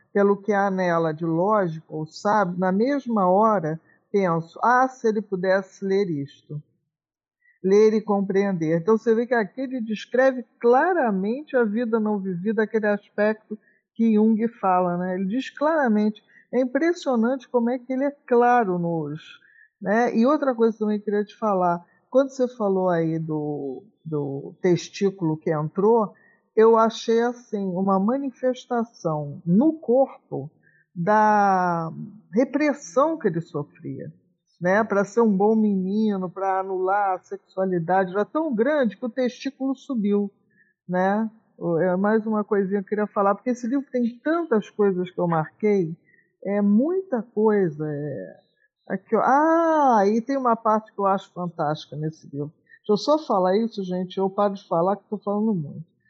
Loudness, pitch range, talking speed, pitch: -23 LUFS, 180-235 Hz, 155 wpm, 205 Hz